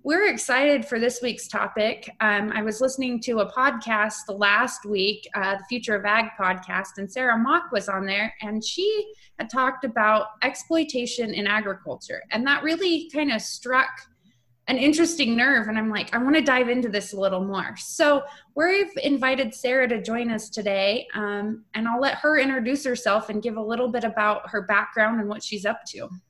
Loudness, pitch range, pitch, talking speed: -23 LUFS, 210-265 Hz, 230 Hz, 190 wpm